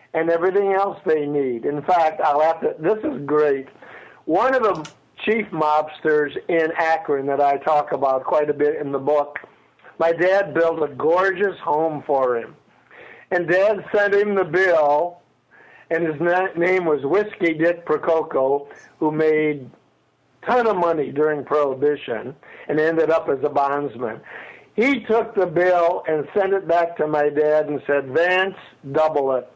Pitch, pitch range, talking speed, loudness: 155 Hz, 145-180 Hz, 165 wpm, -20 LUFS